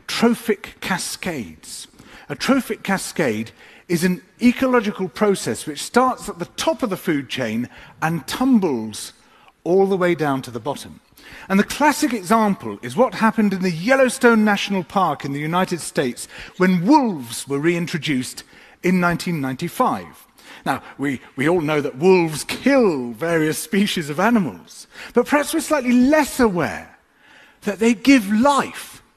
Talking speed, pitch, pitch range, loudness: 145 wpm, 185 Hz, 155-240 Hz, -20 LUFS